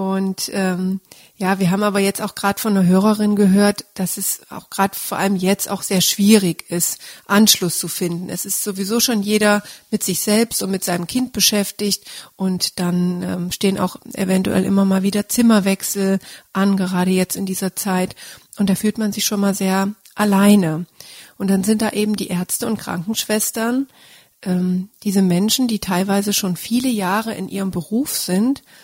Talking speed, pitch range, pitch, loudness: 180 wpm, 185-210 Hz, 195 Hz, -18 LUFS